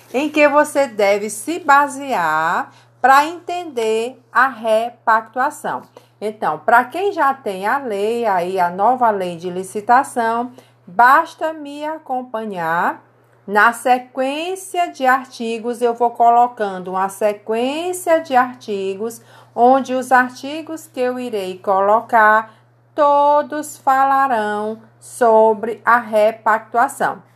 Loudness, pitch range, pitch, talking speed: -17 LUFS, 215-275 Hz, 235 Hz, 105 wpm